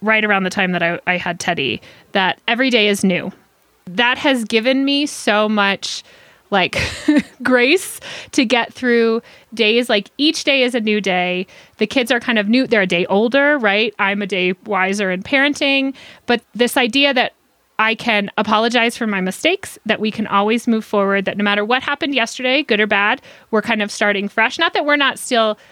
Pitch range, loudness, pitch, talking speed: 205-255 Hz, -16 LUFS, 225 Hz, 200 wpm